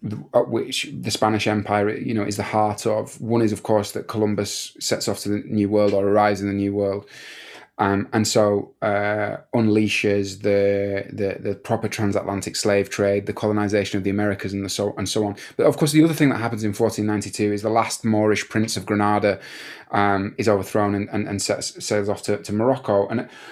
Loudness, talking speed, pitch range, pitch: -22 LUFS, 205 wpm, 100-110 Hz, 105 Hz